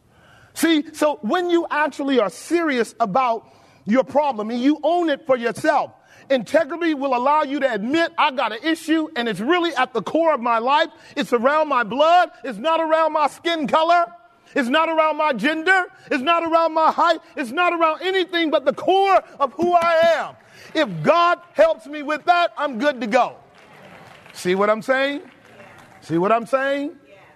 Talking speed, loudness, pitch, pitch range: 185 wpm, -19 LUFS, 305 Hz, 270-330 Hz